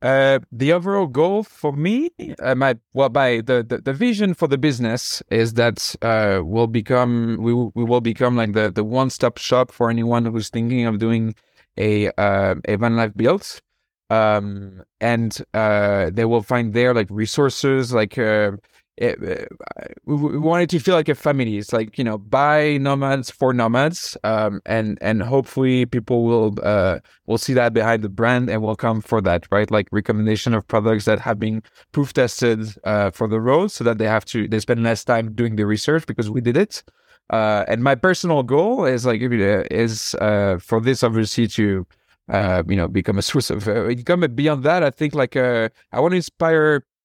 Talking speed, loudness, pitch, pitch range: 195 wpm, -19 LUFS, 115 Hz, 110-130 Hz